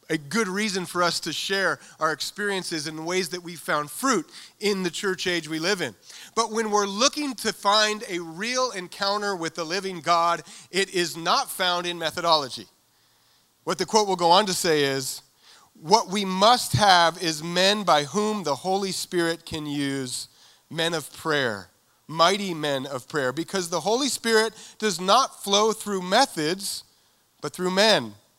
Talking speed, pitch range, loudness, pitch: 175 wpm, 160-205 Hz, -24 LUFS, 180 Hz